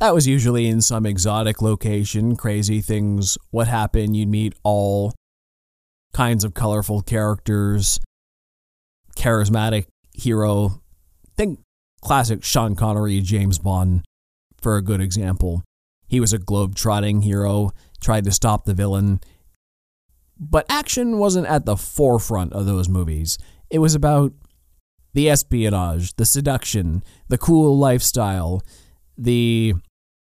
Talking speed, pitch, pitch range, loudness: 120 wpm, 105 Hz, 85-110 Hz, -20 LUFS